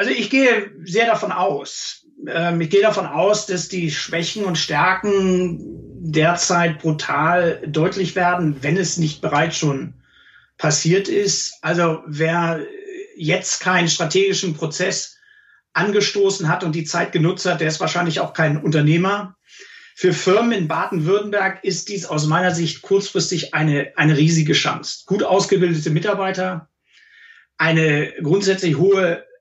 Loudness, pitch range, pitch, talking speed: -19 LUFS, 160-195 Hz, 180 Hz, 135 wpm